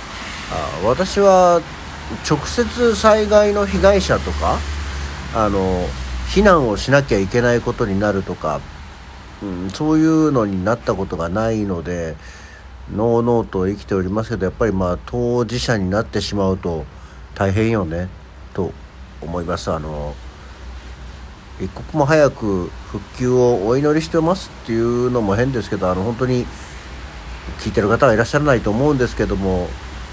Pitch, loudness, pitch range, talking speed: 100 Hz, -18 LUFS, 75-120 Hz, 290 characters per minute